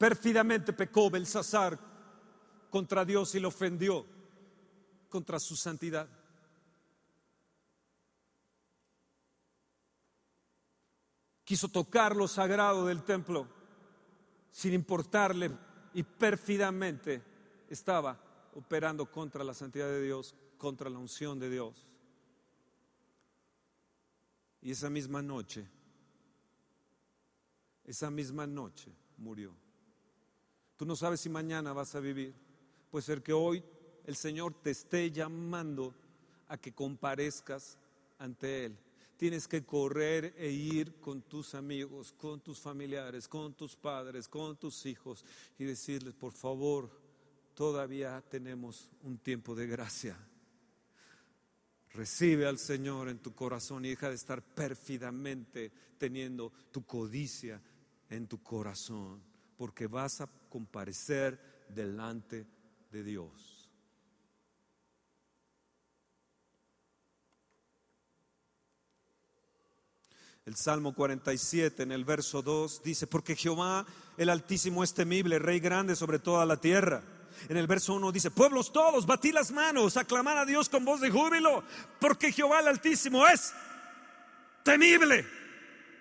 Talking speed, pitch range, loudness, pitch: 110 wpm, 125-190 Hz, -32 LUFS, 145 Hz